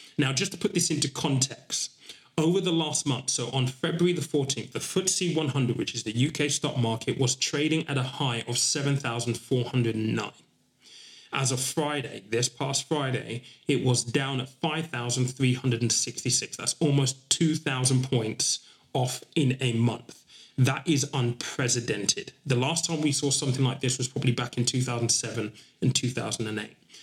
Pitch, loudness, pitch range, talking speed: 130 Hz, -27 LUFS, 120-150 Hz, 155 wpm